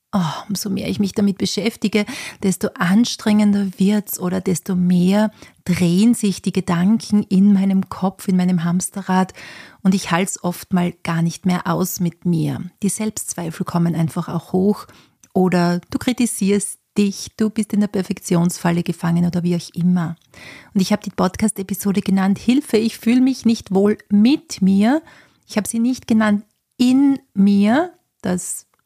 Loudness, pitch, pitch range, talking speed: -19 LUFS, 195 Hz, 180-215 Hz, 160 wpm